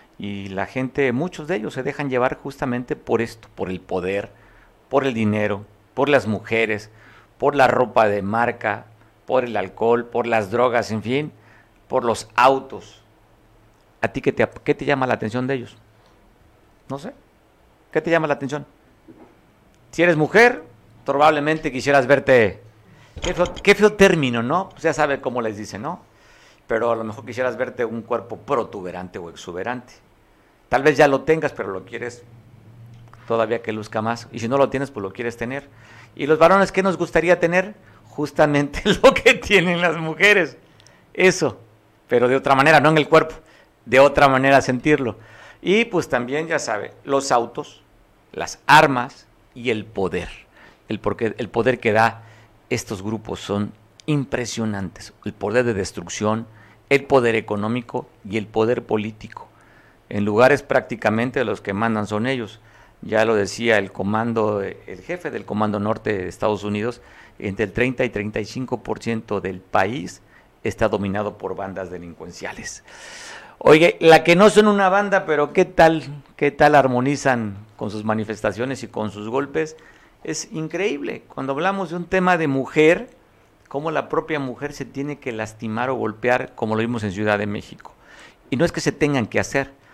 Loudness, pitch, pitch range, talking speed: -20 LUFS, 120 Hz, 110-145 Hz, 165 wpm